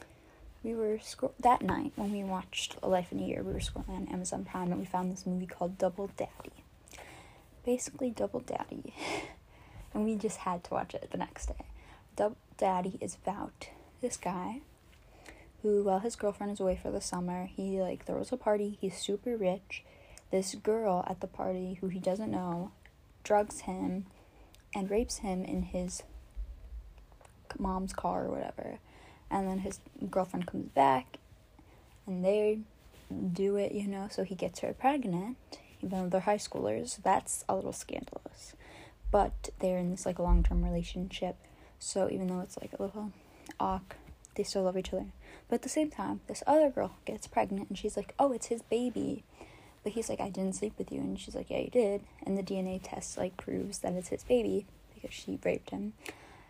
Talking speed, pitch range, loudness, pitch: 185 wpm, 185-215 Hz, -34 LUFS, 195 Hz